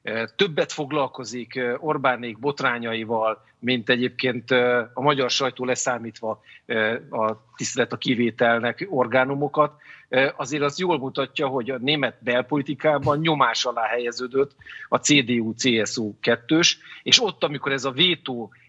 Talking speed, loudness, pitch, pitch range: 110 wpm, -23 LUFS, 130 Hz, 120-145 Hz